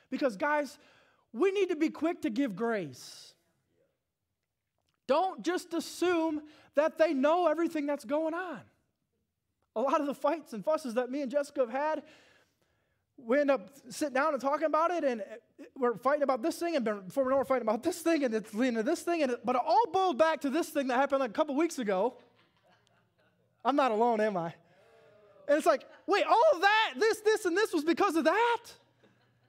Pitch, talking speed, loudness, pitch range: 295 Hz, 205 wpm, -30 LUFS, 260-330 Hz